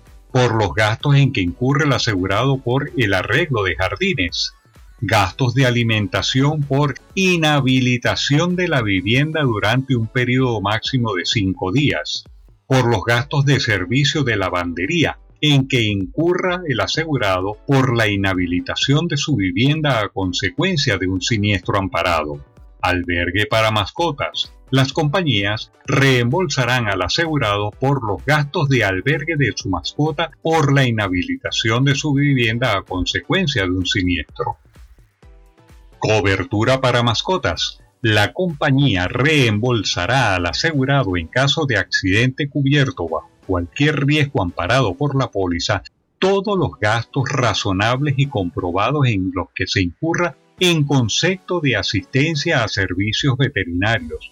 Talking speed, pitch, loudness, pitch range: 130 wpm, 125 Hz, -18 LUFS, 100-145 Hz